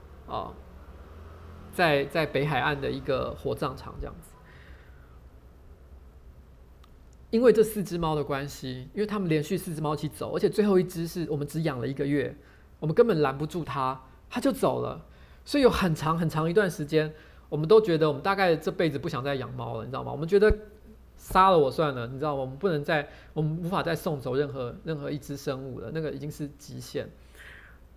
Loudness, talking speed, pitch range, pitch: -27 LUFS, 295 characters per minute, 115-165 Hz, 150 Hz